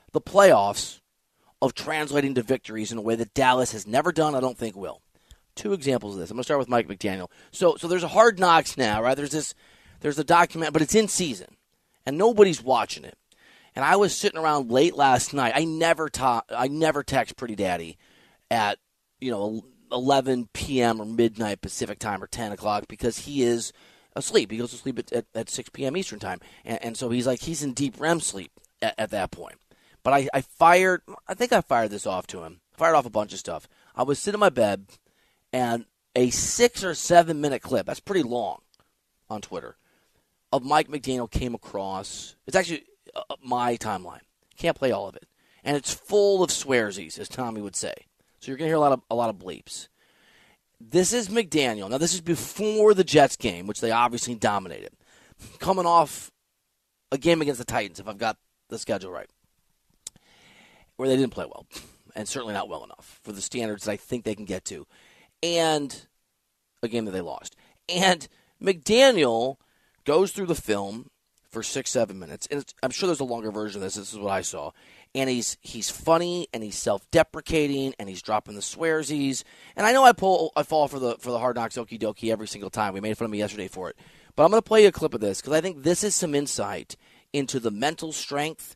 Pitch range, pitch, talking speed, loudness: 115-165 Hz, 130 Hz, 210 wpm, -24 LUFS